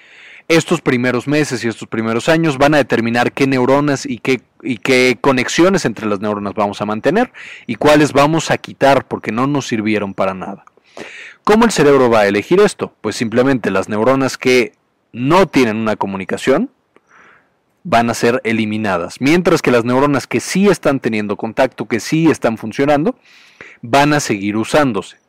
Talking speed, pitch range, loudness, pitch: 170 wpm, 110-145 Hz, -15 LUFS, 125 Hz